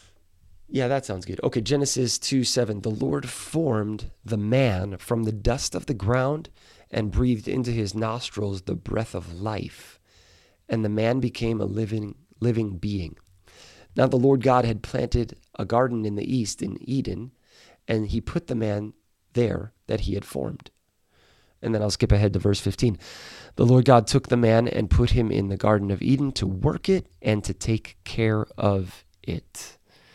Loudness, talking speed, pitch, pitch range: -25 LUFS, 180 wpm, 110 Hz, 100-125 Hz